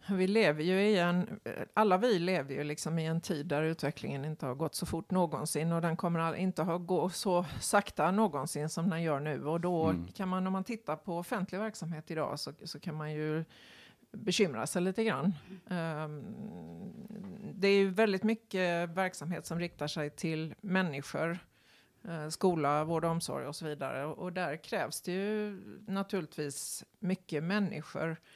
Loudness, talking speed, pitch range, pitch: -34 LUFS, 170 wpm, 155-195 Hz, 175 Hz